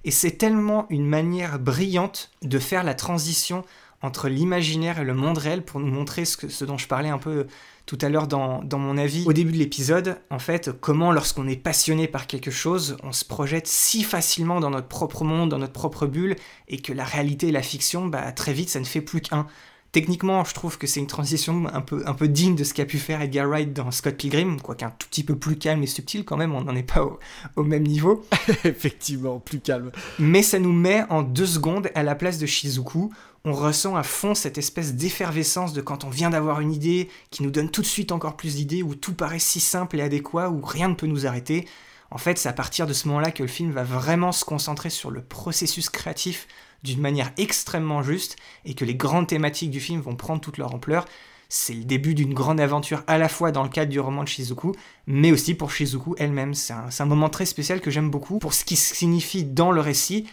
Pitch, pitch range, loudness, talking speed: 155 Hz, 140-170 Hz, -23 LUFS, 240 wpm